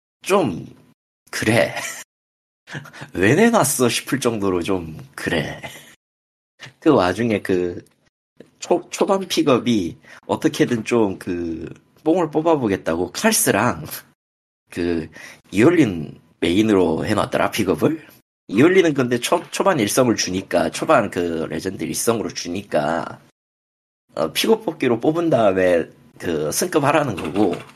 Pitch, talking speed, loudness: 95 Hz, 225 characters per minute, -19 LUFS